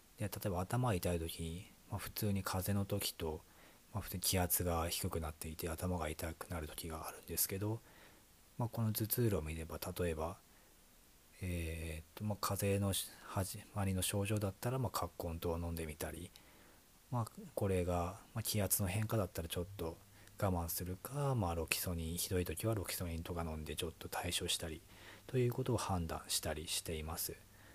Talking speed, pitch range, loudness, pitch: 350 characters per minute, 85-105 Hz, -40 LUFS, 90 Hz